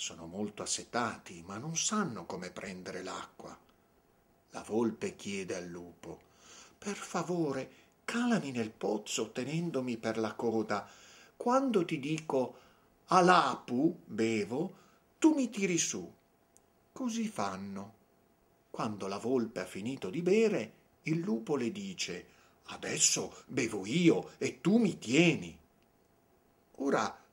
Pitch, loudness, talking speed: 160 Hz, -33 LUFS, 115 wpm